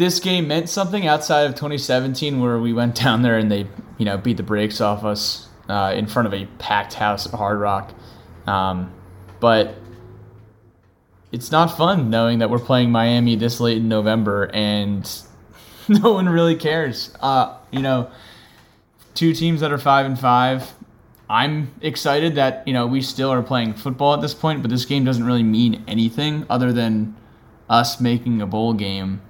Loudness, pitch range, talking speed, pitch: -19 LUFS, 110-140 Hz, 180 wpm, 120 Hz